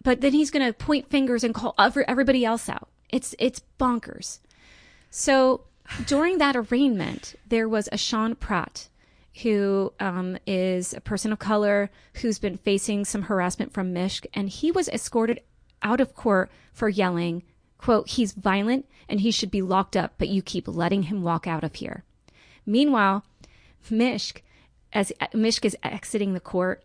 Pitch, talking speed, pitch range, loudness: 215 Hz, 165 wpm, 195-245 Hz, -25 LUFS